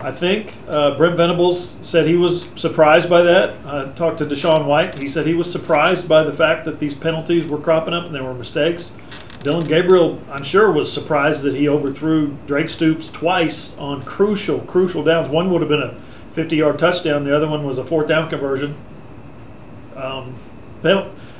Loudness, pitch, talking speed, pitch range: -17 LUFS, 155 Hz, 190 wpm, 145-165 Hz